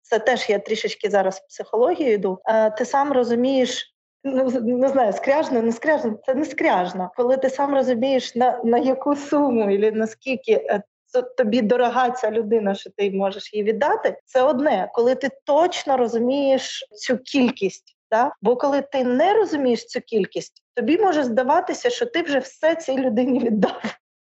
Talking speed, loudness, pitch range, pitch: 160 wpm, -21 LUFS, 230-280 Hz, 255 Hz